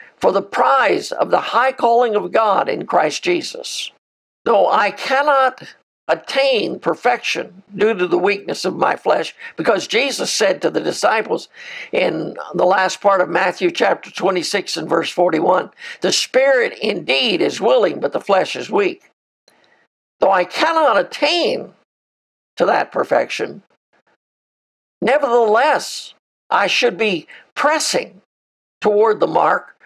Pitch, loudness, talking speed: 265 Hz, -17 LUFS, 135 wpm